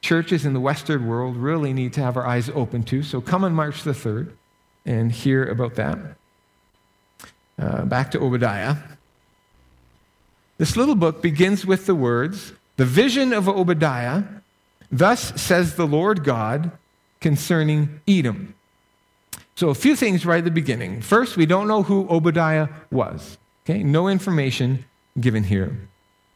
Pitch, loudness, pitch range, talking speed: 145 Hz, -21 LUFS, 120-175 Hz, 150 wpm